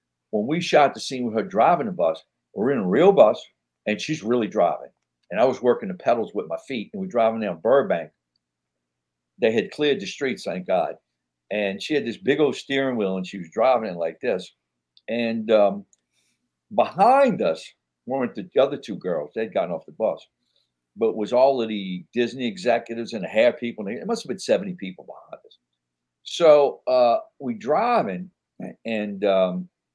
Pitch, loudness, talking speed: 110 Hz, -23 LUFS, 190 wpm